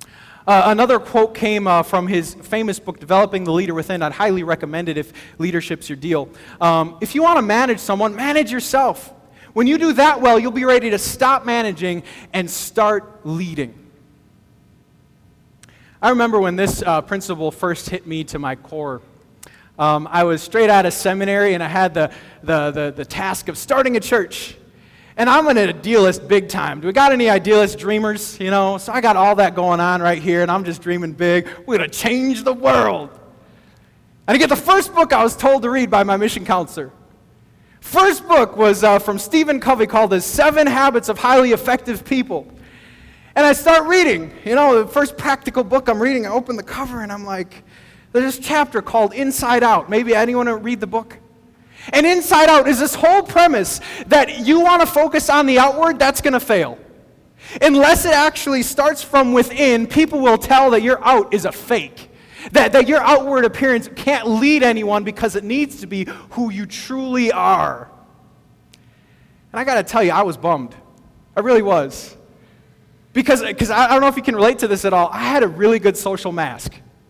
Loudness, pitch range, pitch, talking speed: -16 LUFS, 185-270 Hz, 225 Hz, 195 wpm